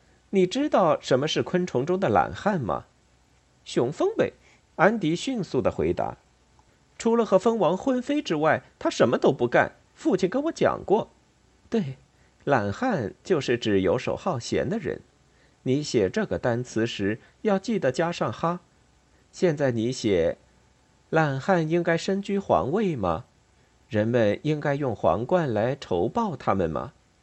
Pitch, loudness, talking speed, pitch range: 160 Hz, -25 LUFS, 210 characters per minute, 120-195 Hz